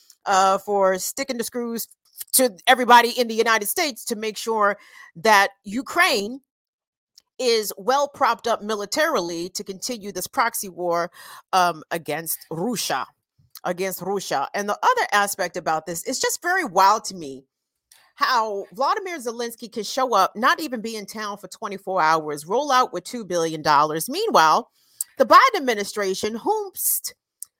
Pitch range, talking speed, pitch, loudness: 190-260 Hz, 150 wpm, 220 Hz, -21 LUFS